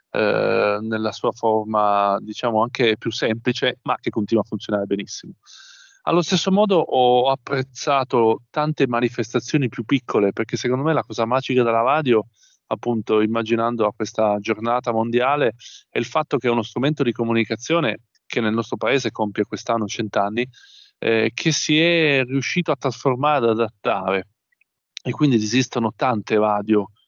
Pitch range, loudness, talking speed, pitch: 110-135 Hz, -21 LUFS, 150 wpm, 120 Hz